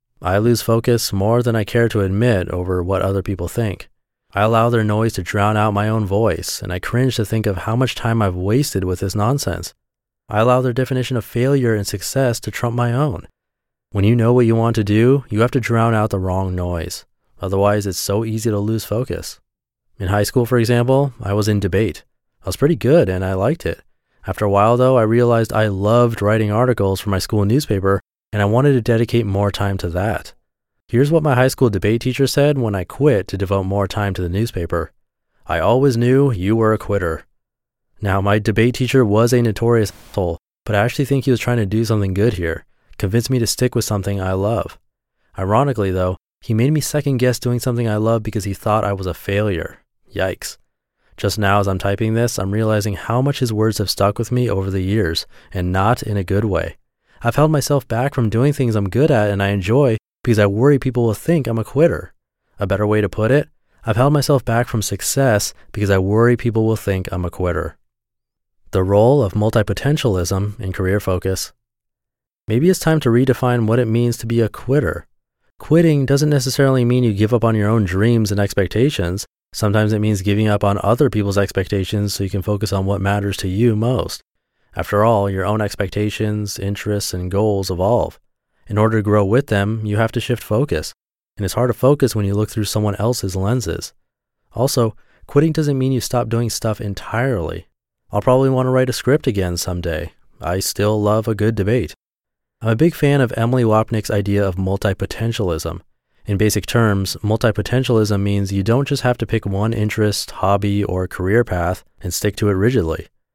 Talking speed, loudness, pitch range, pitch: 210 wpm, -18 LUFS, 100-120 Hz, 110 Hz